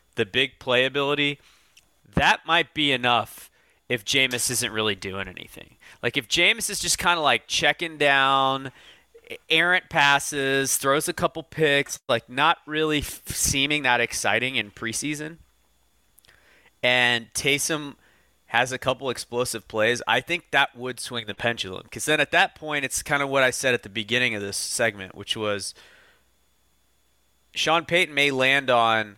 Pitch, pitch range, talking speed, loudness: 130 Hz, 115-145 Hz, 155 wpm, -22 LUFS